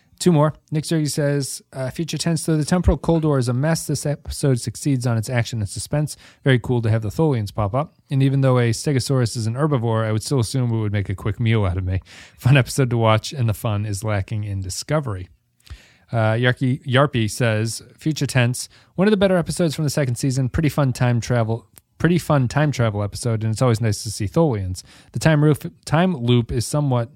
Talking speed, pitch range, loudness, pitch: 225 wpm, 110-150 Hz, -21 LUFS, 125 Hz